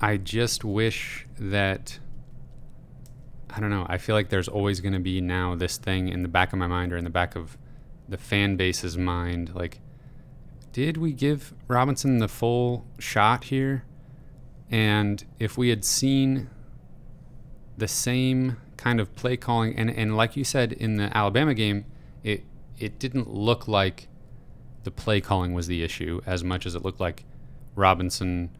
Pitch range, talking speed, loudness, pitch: 95-130 Hz, 170 wpm, -26 LUFS, 115 Hz